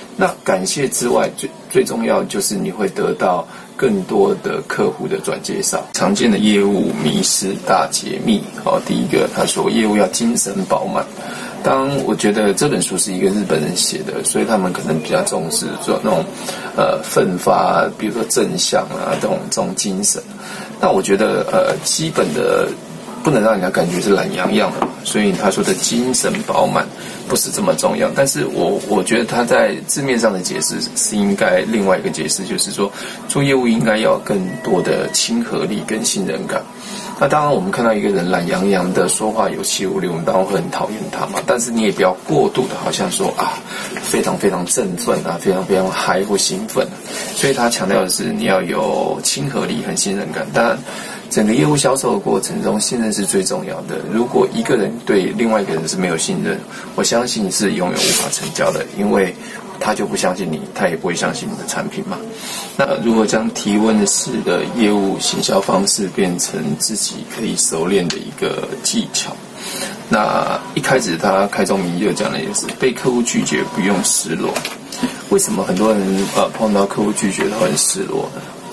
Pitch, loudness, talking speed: 120 Hz, -17 LUFS, 285 characters per minute